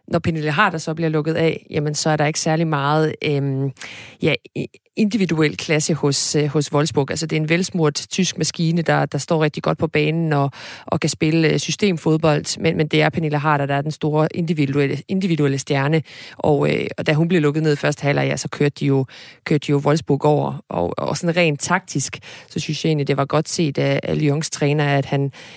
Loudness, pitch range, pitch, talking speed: -19 LUFS, 145-160 Hz, 155 Hz, 220 wpm